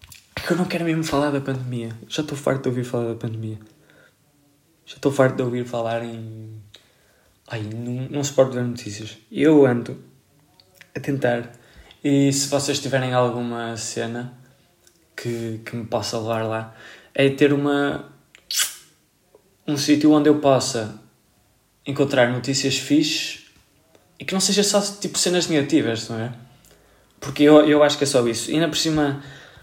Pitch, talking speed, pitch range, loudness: 130 Hz, 160 wpm, 115-145 Hz, -21 LUFS